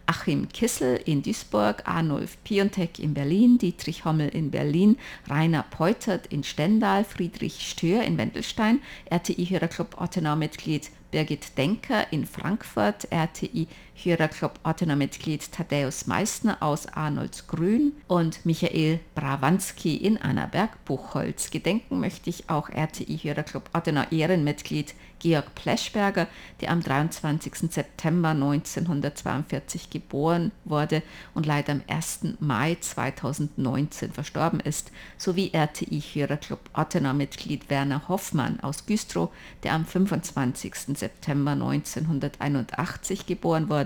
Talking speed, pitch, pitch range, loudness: 115 wpm, 160 Hz, 145-185 Hz, -27 LUFS